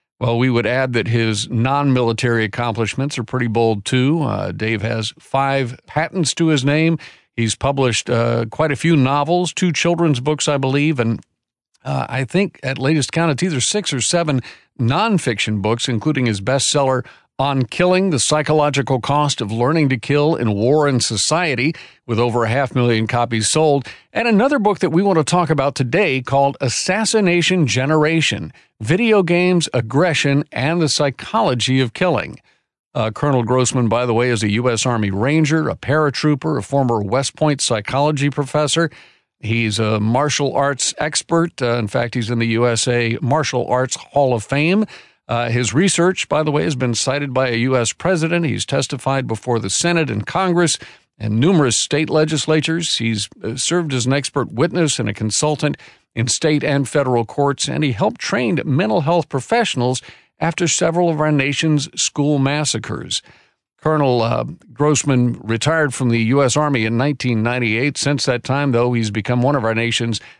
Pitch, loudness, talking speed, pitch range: 135 Hz, -17 LUFS, 170 wpm, 120-155 Hz